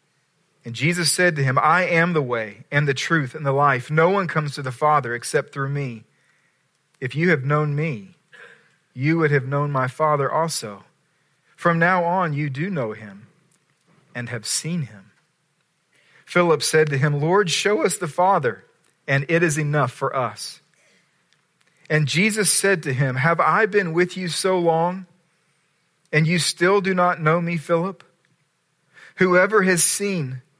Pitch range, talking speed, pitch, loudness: 145-175 Hz, 165 wpm, 155 Hz, -20 LUFS